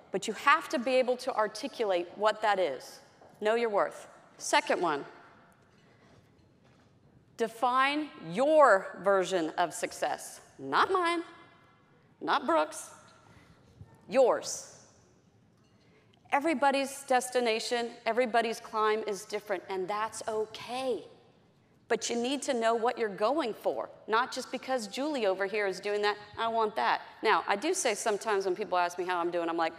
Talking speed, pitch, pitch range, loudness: 140 wpm, 225 Hz, 205-265 Hz, -30 LUFS